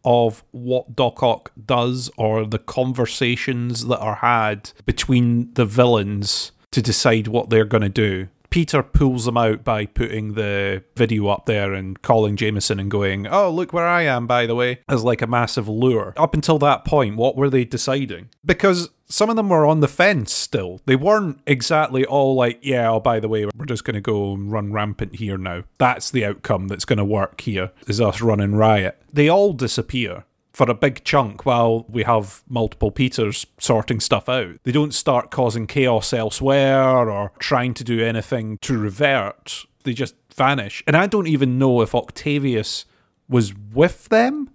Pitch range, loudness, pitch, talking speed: 110-135 Hz, -19 LUFS, 120 Hz, 185 wpm